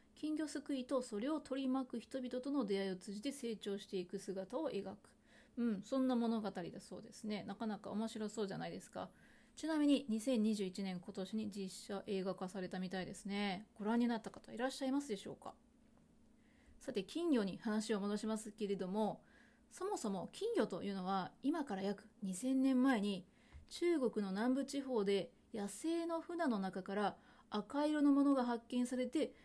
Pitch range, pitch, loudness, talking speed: 200-265 Hz, 220 Hz, -40 LUFS, 335 characters per minute